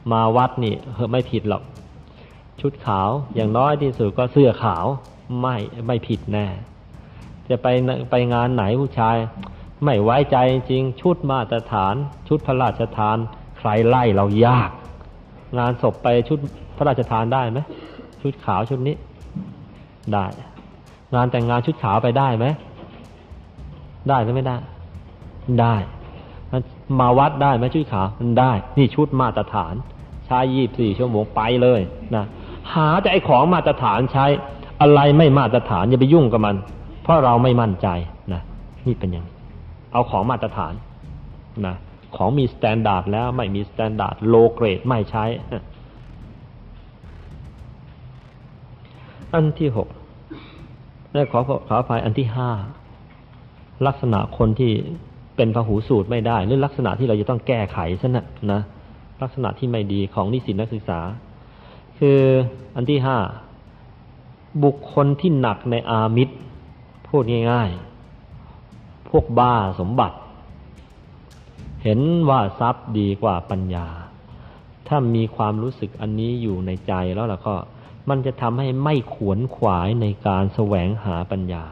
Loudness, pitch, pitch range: -20 LUFS, 120 Hz, 105-130 Hz